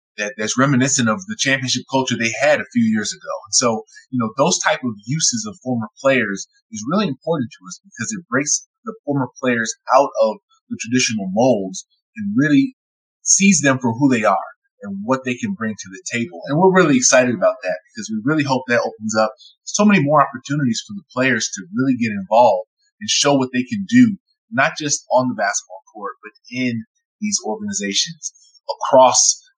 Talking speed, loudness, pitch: 195 wpm, -18 LUFS, 145 Hz